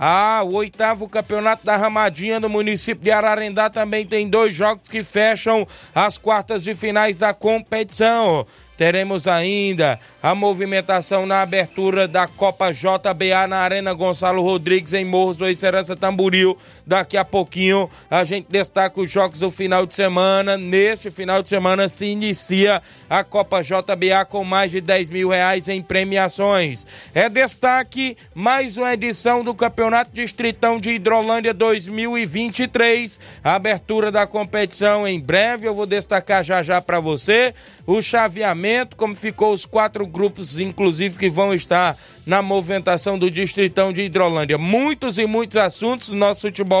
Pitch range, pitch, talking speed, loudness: 190-220 Hz, 200 Hz, 150 wpm, -18 LUFS